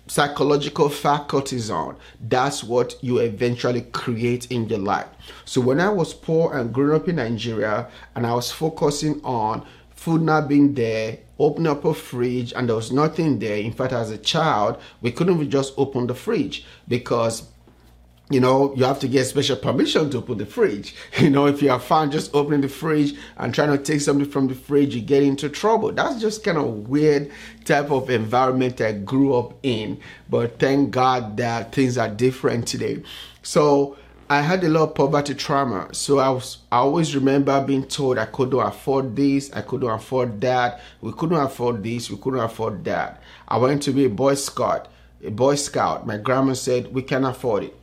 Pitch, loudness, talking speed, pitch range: 130 Hz, -21 LUFS, 195 wpm, 120-145 Hz